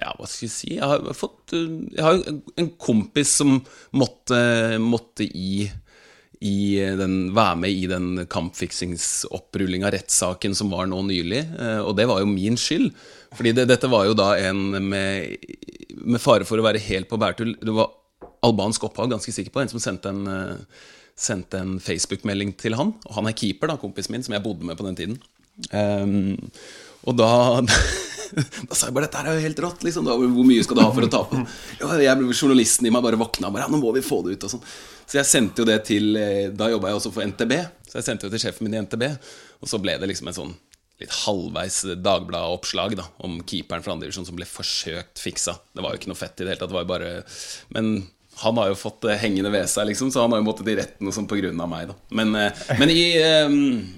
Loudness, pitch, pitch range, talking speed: -22 LUFS, 110 Hz, 95-120 Hz, 200 wpm